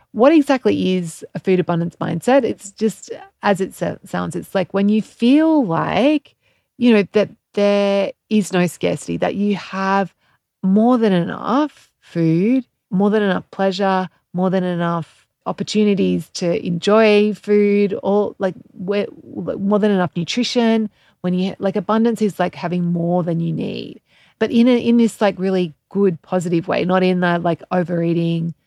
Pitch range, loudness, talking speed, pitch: 180-215 Hz, -18 LUFS, 160 wpm, 195 Hz